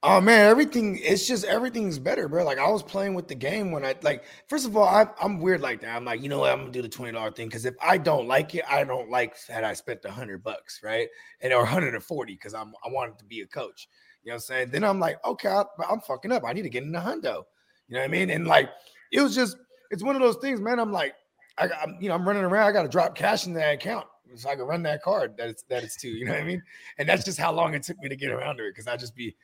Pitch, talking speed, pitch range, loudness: 185 Hz, 305 wpm, 135-225 Hz, -25 LUFS